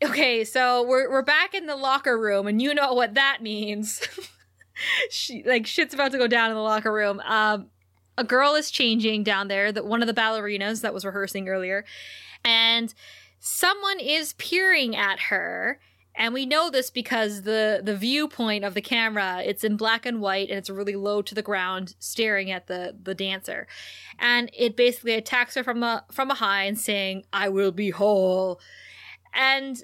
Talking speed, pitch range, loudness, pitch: 185 wpm, 200-255 Hz, -23 LUFS, 225 Hz